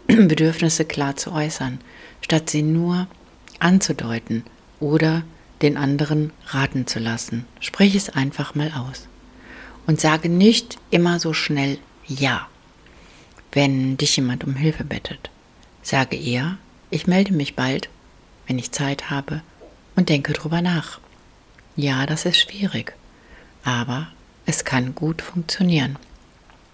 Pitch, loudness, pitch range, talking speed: 150 Hz, -21 LUFS, 135-170 Hz, 125 wpm